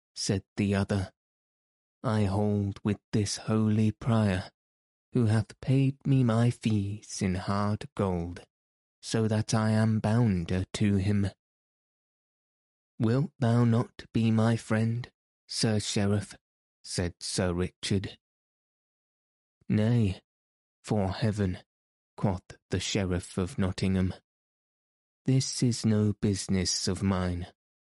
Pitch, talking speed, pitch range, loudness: 105 Hz, 110 wpm, 95-115 Hz, -29 LUFS